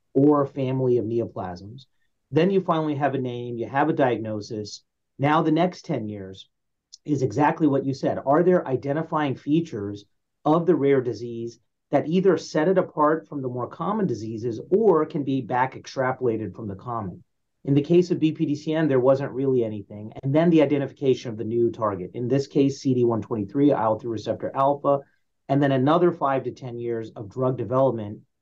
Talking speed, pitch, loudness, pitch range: 180 wpm, 135 Hz, -23 LUFS, 115-150 Hz